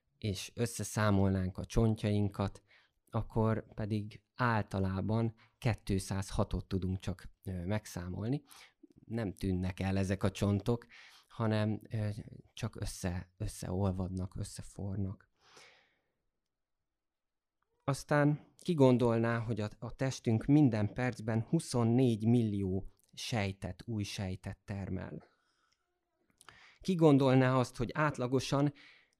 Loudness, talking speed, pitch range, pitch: -34 LUFS, 80 wpm, 95-120 Hz, 105 Hz